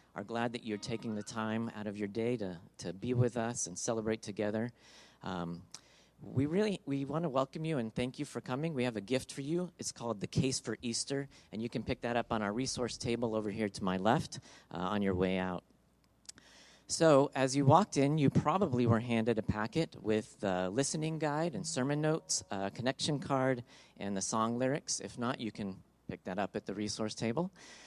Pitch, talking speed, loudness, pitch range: 120 Hz, 215 wpm, -35 LUFS, 105-140 Hz